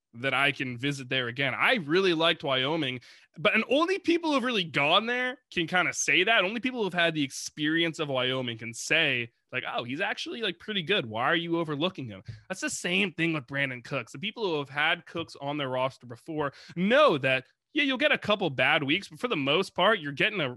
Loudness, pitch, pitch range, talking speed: -27 LUFS, 160 Hz, 135-200 Hz, 235 wpm